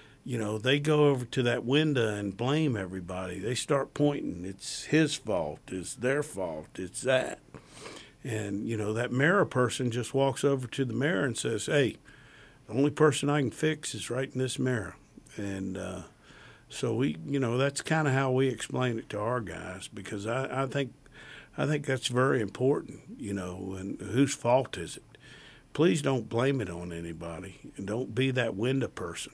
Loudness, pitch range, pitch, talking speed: -30 LUFS, 110-140 Hz, 130 Hz, 185 wpm